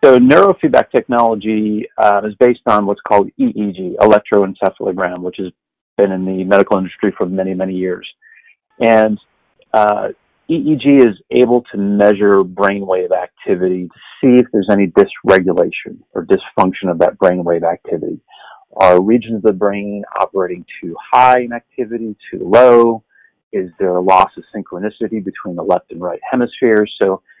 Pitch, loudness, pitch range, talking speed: 105 Hz, -14 LUFS, 95-115 Hz, 150 wpm